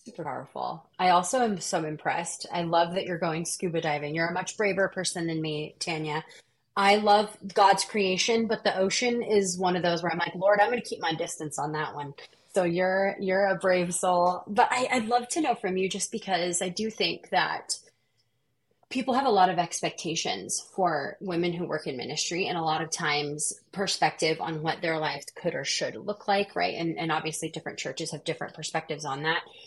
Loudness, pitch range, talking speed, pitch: -27 LUFS, 160-200 Hz, 210 wpm, 180 Hz